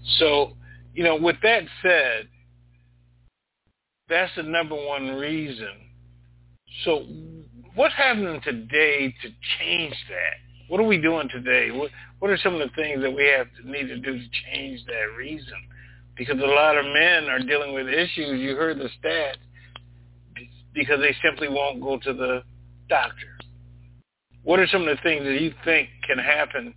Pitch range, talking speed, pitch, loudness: 120-155 Hz, 165 wpm, 135 Hz, -22 LUFS